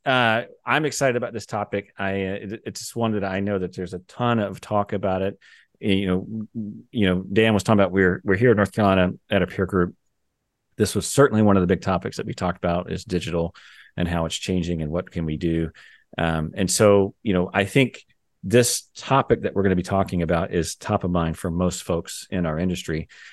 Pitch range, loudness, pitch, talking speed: 90-105 Hz, -23 LUFS, 95 Hz, 230 wpm